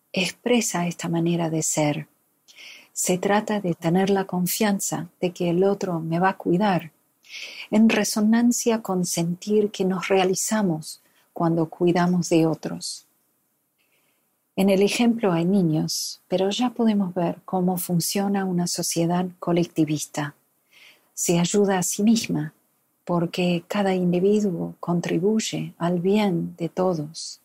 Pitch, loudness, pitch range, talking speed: 180 Hz, -23 LUFS, 170-200 Hz, 125 wpm